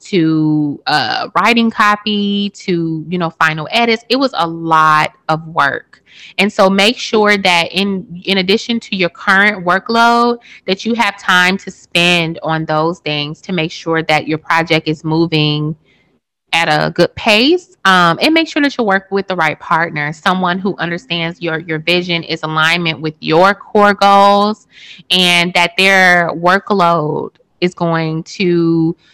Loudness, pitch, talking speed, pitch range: -13 LUFS, 175 Hz, 160 wpm, 160-200 Hz